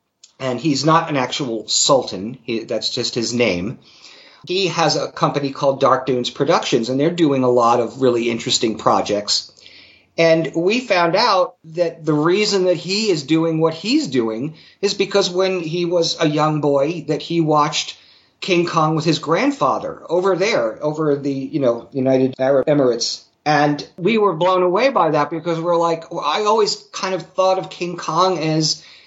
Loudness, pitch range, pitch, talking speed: -18 LUFS, 135-180 Hz, 160 Hz, 180 wpm